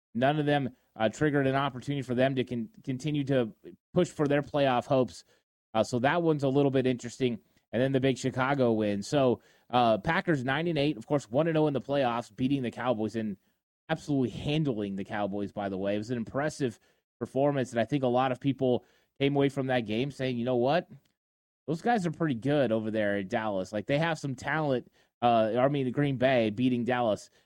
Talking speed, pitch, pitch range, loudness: 215 wpm, 130 Hz, 115-145 Hz, -29 LUFS